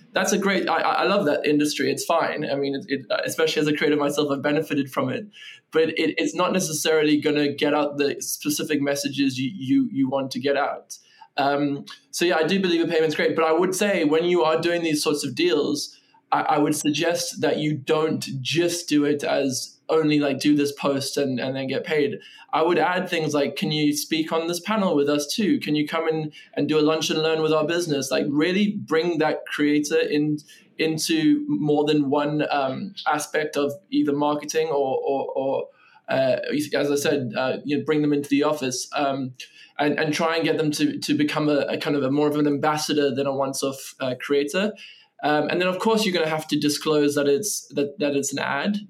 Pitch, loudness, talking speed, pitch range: 150 Hz, -23 LUFS, 225 wpm, 145-170 Hz